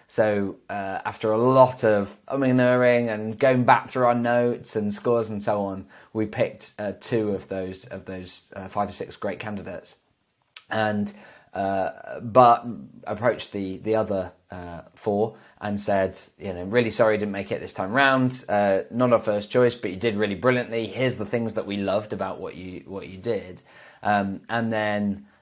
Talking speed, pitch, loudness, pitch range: 185 wpm, 105 Hz, -24 LUFS, 100-120 Hz